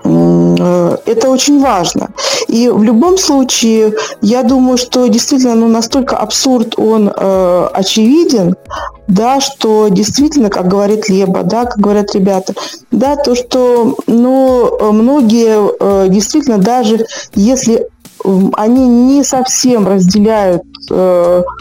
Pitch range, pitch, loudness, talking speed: 200-260 Hz, 230 Hz, -10 LUFS, 110 wpm